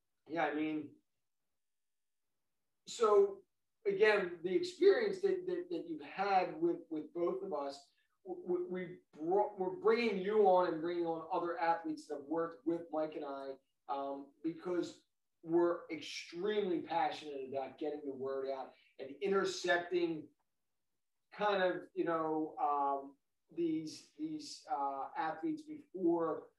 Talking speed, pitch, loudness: 130 wpm, 175 Hz, -37 LUFS